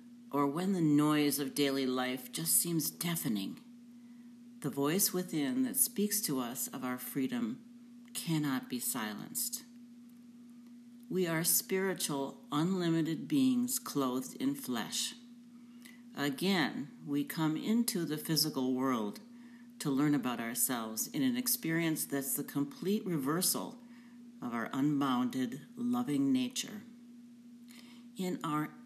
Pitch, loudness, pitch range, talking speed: 225 Hz, -33 LUFS, 150-240 Hz, 115 wpm